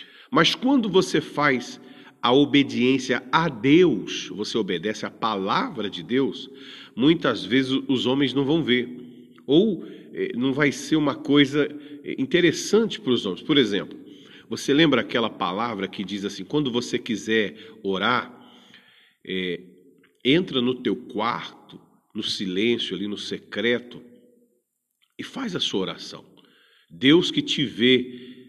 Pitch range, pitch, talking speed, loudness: 115-145 Hz, 130 Hz, 135 wpm, -23 LUFS